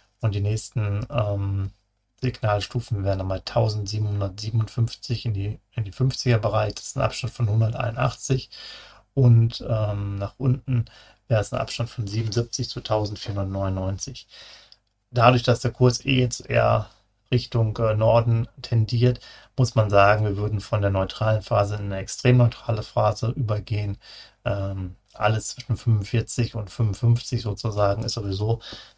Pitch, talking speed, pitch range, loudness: 110 Hz, 135 wpm, 105-120 Hz, -24 LUFS